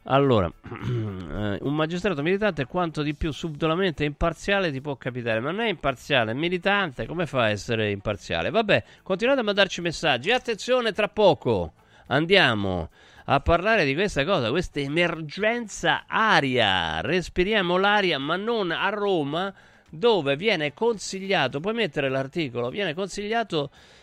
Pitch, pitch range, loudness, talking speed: 170 Hz, 135-200 Hz, -24 LUFS, 130 wpm